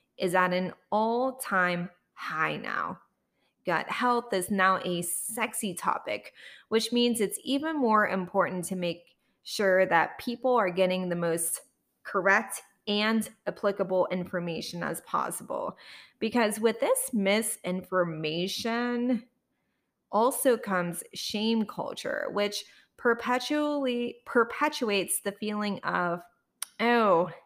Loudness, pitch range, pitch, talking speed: -28 LUFS, 185-240 Hz, 205 Hz, 105 wpm